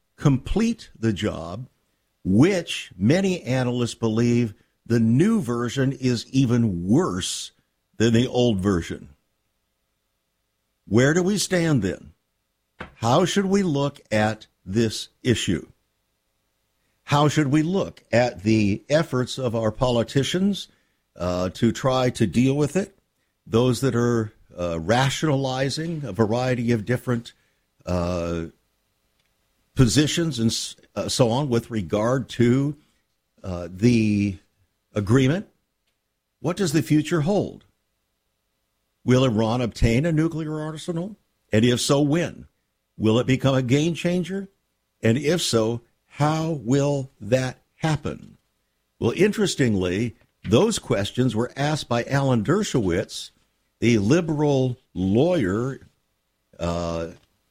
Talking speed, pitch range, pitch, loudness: 110 wpm, 110-150 Hz, 125 Hz, -23 LUFS